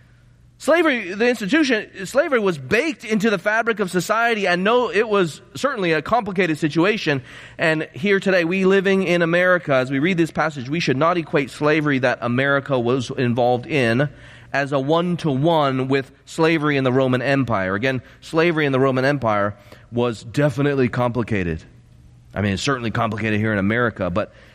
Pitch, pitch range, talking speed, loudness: 140 Hz, 125-180 Hz, 170 wpm, -20 LUFS